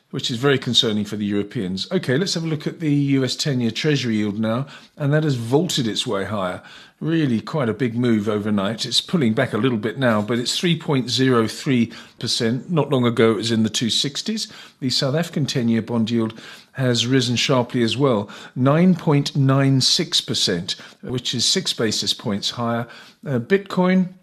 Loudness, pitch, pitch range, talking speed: -20 LUFS, 125 Hz, 115-145 Hz, 180 wpm